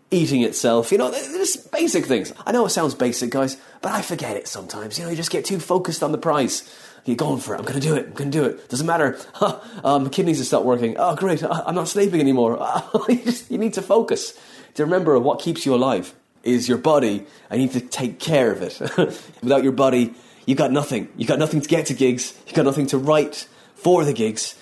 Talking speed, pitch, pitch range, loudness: 245 wpm, 150 Hz, 130-180 Hz, -21 LUFS